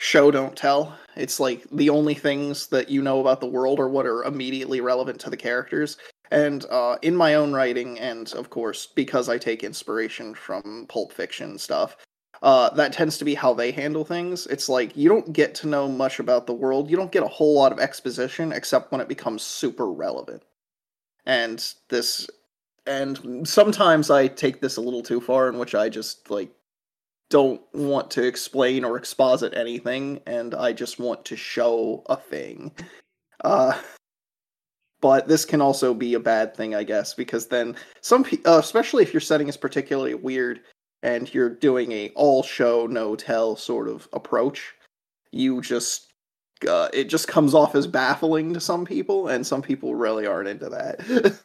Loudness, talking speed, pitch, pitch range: -23 LUFS, 185 wpm, 135 Hz, 125-150 Hz